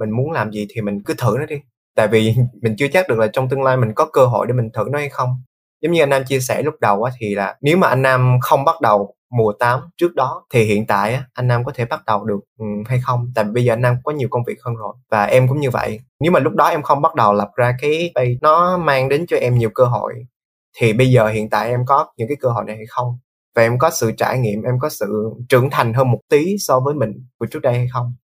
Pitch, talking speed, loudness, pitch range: 125 Hz, 290 wpm, -17 LUFS, 110-135 Hz